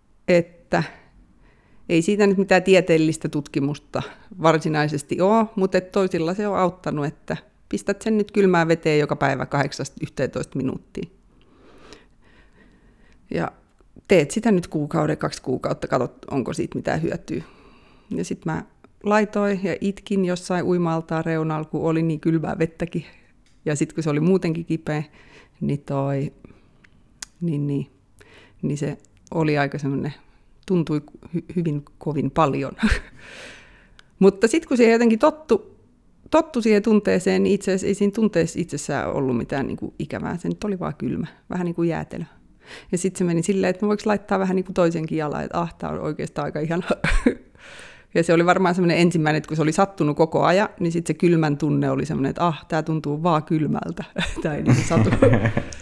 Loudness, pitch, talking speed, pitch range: -22 LUFS, 170 Hz, 160 wpm, 150-190 Hz